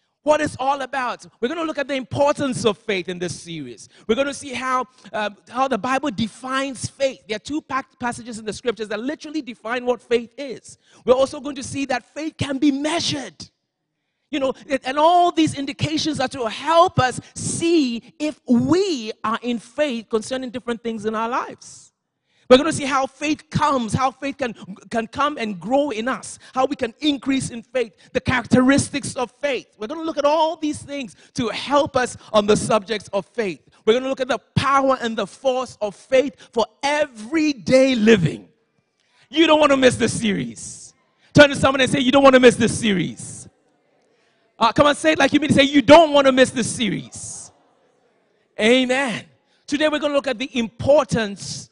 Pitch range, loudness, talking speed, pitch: 225-285 Hz, -20 LUFS, 195 wpm, 255 Hz